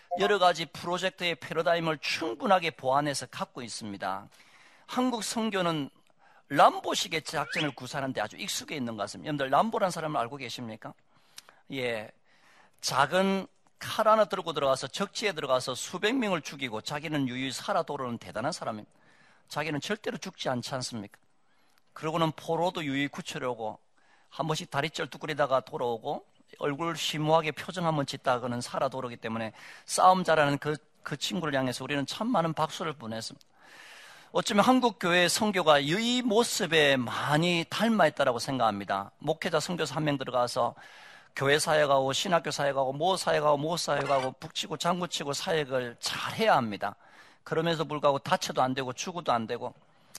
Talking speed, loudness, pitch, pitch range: 370 characters per minute, -29 LUFS, 155 Hz, 135-175 Hz